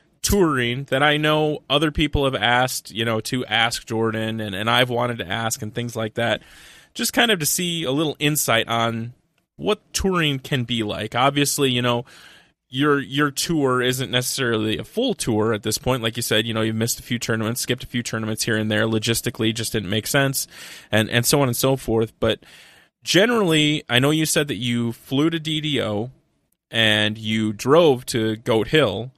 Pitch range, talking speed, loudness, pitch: 110-145 Hz, 200 wpm, -21 LUFS, 120 Hz